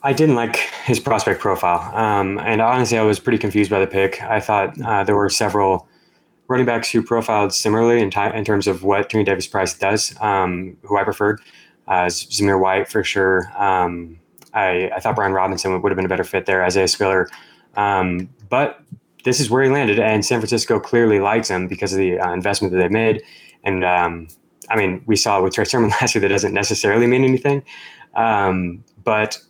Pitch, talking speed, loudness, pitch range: 100 Hz, 210 wpm, -18 LUFS, 95-110 Hz